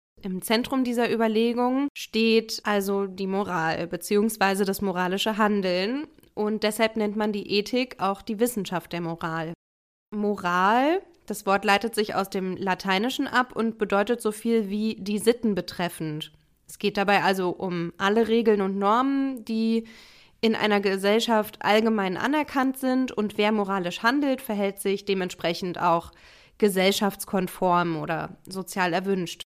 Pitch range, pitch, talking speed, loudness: 190-225 Hz, 205 Hz, 140 wpm, -25 LUFS